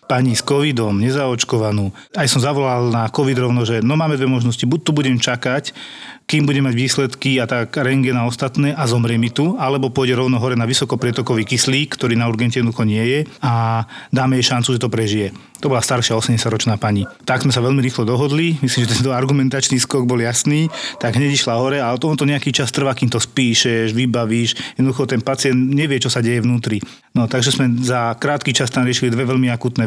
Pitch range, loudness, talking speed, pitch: 120-135 Hz, -17 LUFS, 205 wpm, 130 Hz